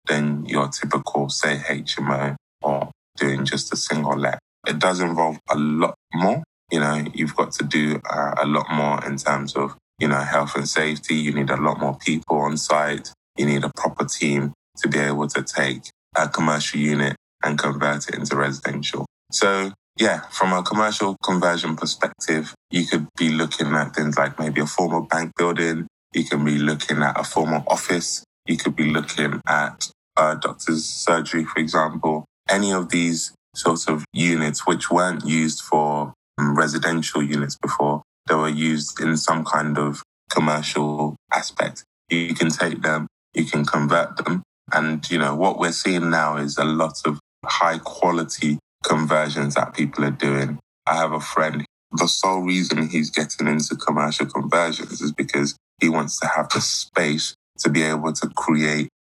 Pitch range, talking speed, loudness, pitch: 75-80 Hz, 175 wpm, -22 LUFS, 75 Hz